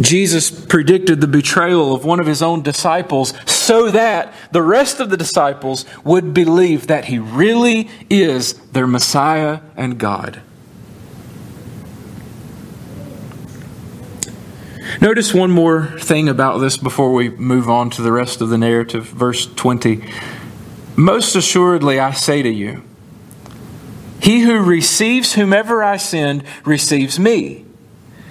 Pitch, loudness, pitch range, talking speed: 150 Hz, -14 LUFS, 125-180 Hz, 125 wpm